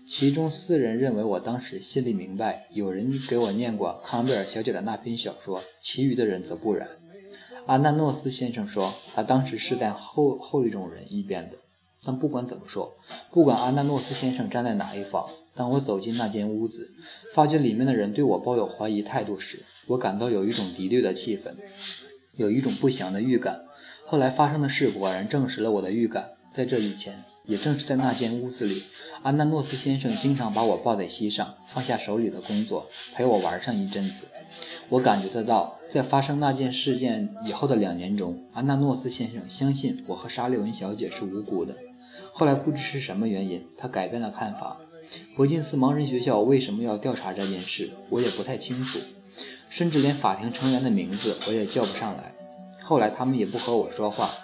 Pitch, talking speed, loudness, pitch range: 130 Hz, 300 characters per minute, -25 LUFS, 105-150 Hz